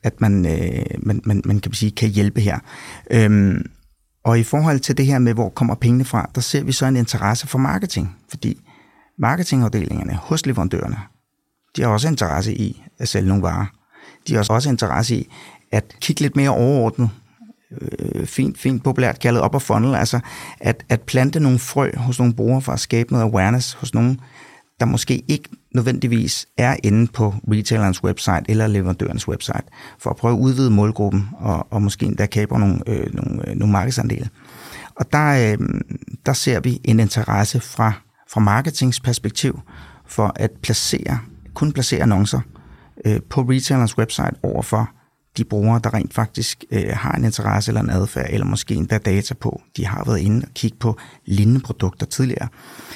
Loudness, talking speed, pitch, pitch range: -19 LUFS, 175 wpm, 115 Hz, 105-130 Hz